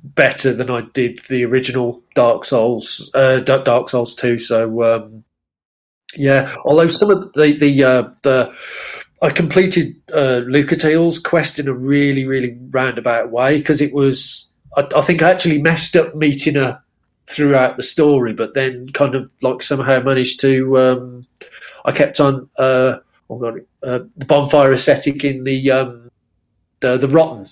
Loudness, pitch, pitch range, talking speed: -15 LUFS, 135 Hz, 125-145 Hz, 165 wpm